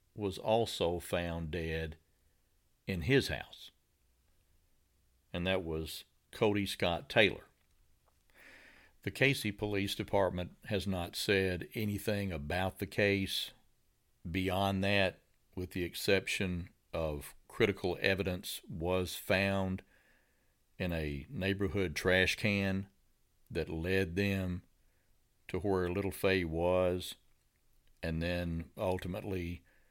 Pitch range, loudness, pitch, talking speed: 80-95 Hz, -34 LUFS, 90 Hz, 100 wpm